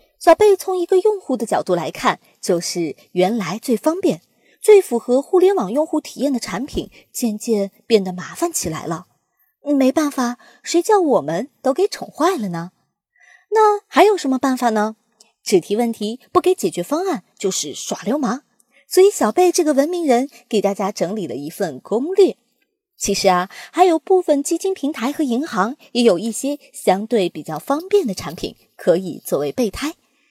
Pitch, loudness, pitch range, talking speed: 260 Hz, -19 LUFS, 205-340 Hz, 255 characters per minute